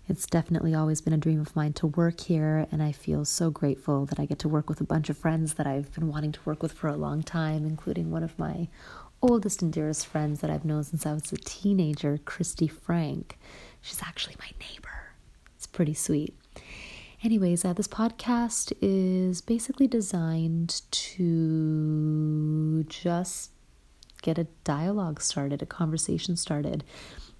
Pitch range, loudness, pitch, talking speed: 150-175 Hz, -28 LUFS, 160 Hz, 170 wpm